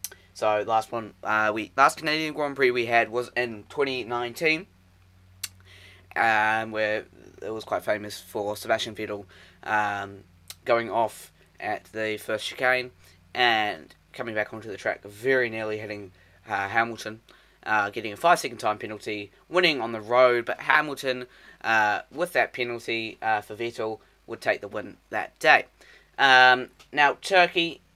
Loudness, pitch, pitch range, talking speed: -25 LUFS, 110 Hz, 100-125 Hz, 155 wpm